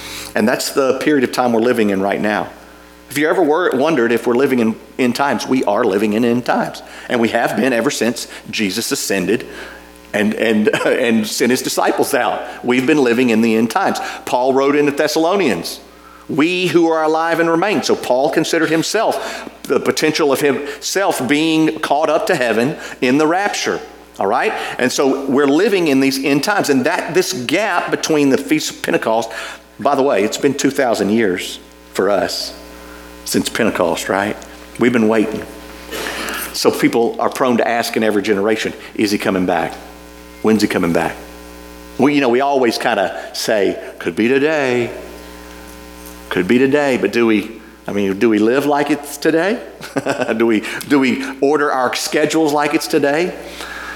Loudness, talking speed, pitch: -16 LUFS, 180 wpm, 115 Hz